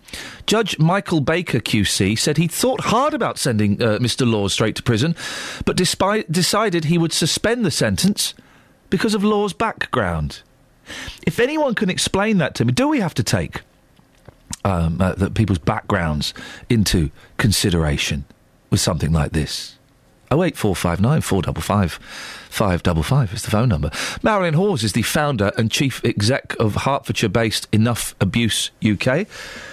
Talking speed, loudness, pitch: 160 wpm, -19 LUFS, 125 Hz